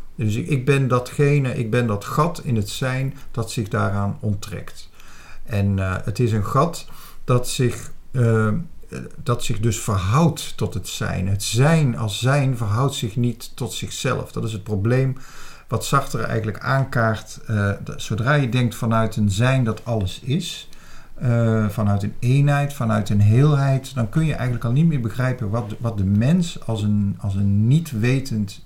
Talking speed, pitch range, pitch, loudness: 175 wpm, 110-135 Hz, 120 Hz, -21 LUFS